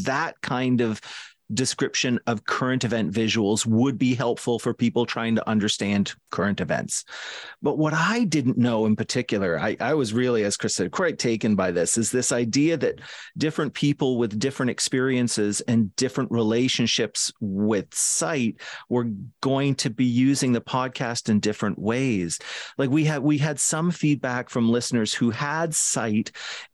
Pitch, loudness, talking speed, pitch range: 125 Hz, -24 LUFS, 160 wpm, 115-135 Hz